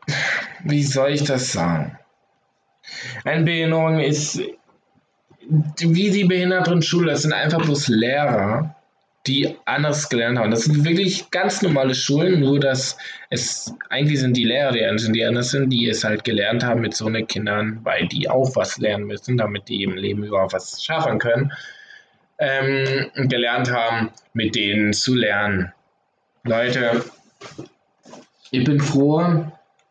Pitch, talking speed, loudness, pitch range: 135 Hz, 140 wpm, -20 LUFS, 115-155 Hz